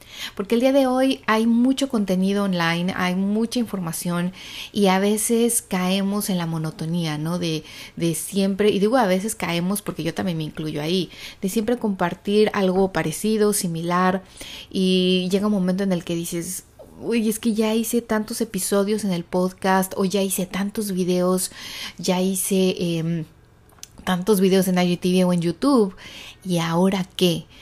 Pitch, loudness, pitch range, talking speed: 190 Hz, -22 LUFS, 180-210 Hz, 165 wpm